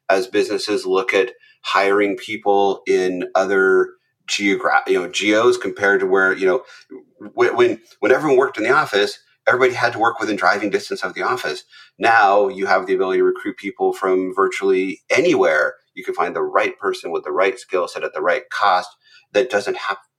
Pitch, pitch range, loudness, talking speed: 375 Hz, 360-400 Hz, -18 LUFS, 185 wpm